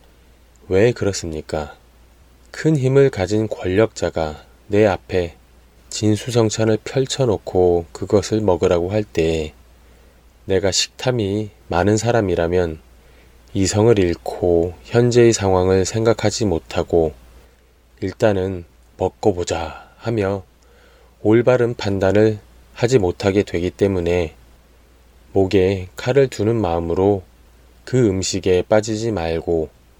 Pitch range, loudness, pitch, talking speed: 75-110 Hz, -19 LUFS, 90 Hz, 220 characters per minute